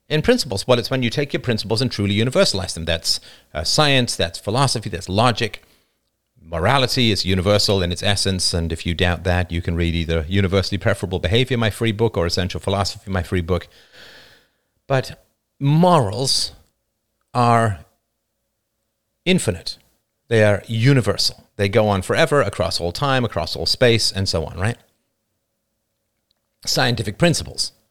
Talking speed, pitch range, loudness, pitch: 150 wpm, 95-120 Hz, -19 LUFS, 110 Hz